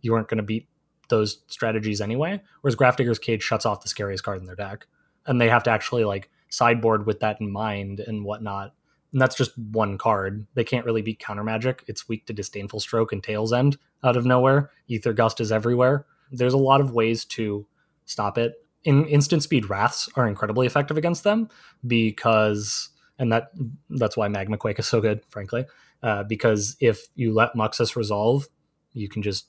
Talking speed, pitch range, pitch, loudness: 195 wpm, 105-130 Hz, 115 Hz, -24 LUFS